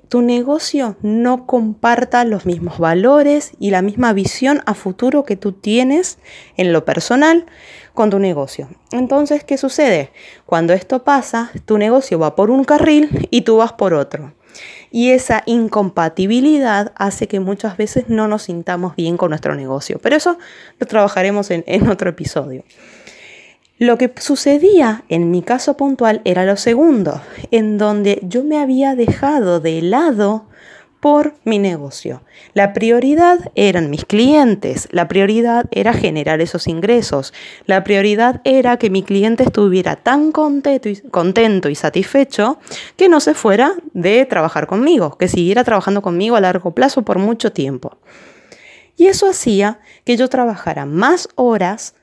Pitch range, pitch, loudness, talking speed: 185-265 Hz, 220 Hz, -14 LUFS, 150 wpm